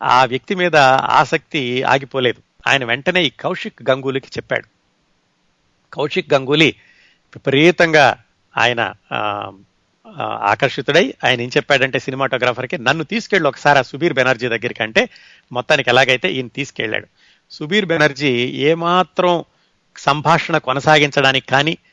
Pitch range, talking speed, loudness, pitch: 130-165 Hz, 100 wpm, -16 LUFS, 140 Hz